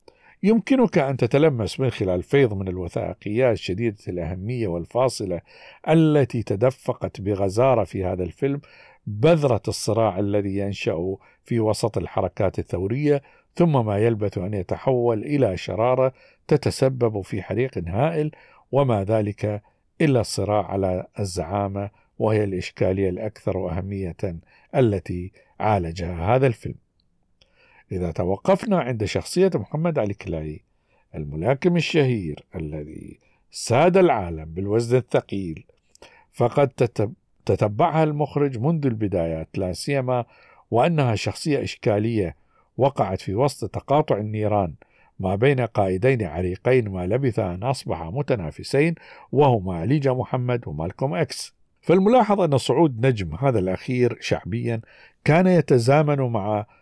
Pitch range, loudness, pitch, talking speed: 95-135 Hz, -23 LUFS, 110 Hz, 110 wpm